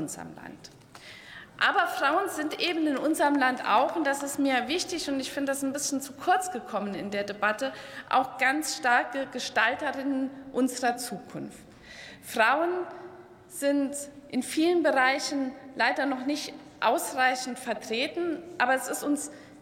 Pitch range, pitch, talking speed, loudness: 255-300 Hz, 275 Hz, 145 wpm, -27 LUFS